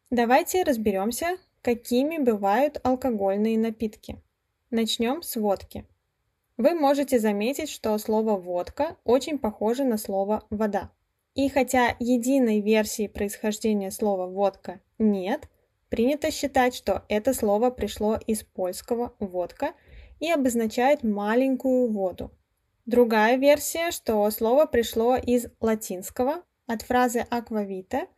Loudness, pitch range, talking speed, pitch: -25 LUFS, 210-260 Hz, 110 wpm, 230 Hz